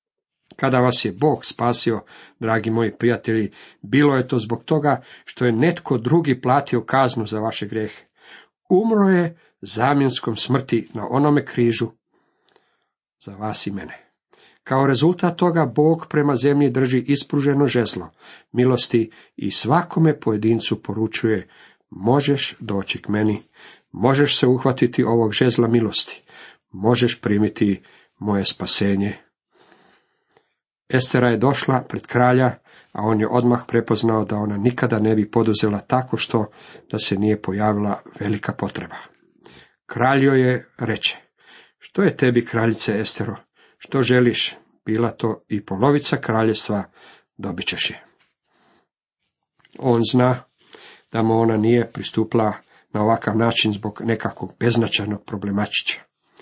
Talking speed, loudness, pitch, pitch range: 125 wpm, -20 LUFS, 115 Hz, 110-130 Hz